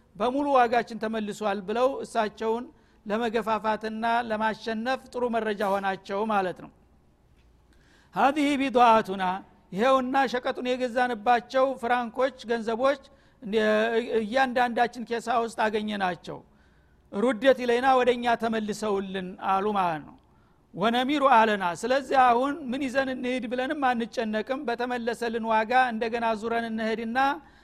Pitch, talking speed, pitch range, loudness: 230 Hz, 100 wpm, 215-255 Hz, -26 LUFS